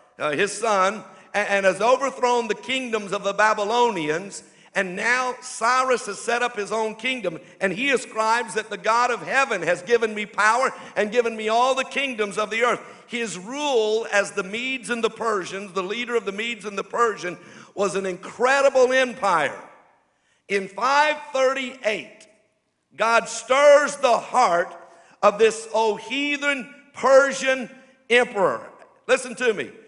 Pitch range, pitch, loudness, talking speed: 205-255 Hz, 225 Hz, -22 LUFS, 155 wpm